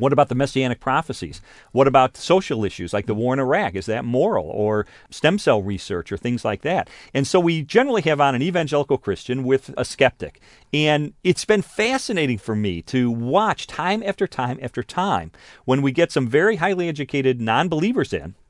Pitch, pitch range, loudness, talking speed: 135 Hz, 115-170 Hz, -21 LUFS, 195 wpm